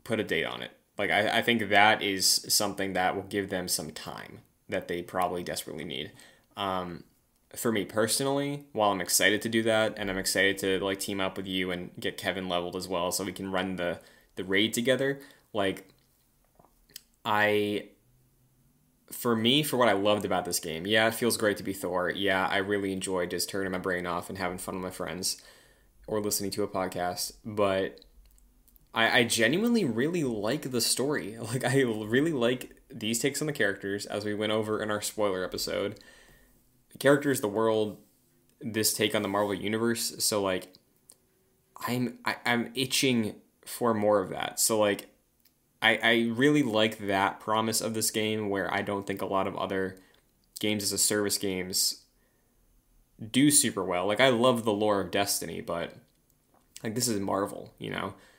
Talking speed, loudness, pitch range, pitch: 185 wpm, -28 LUFS, 95-115 Hz, 105 Hz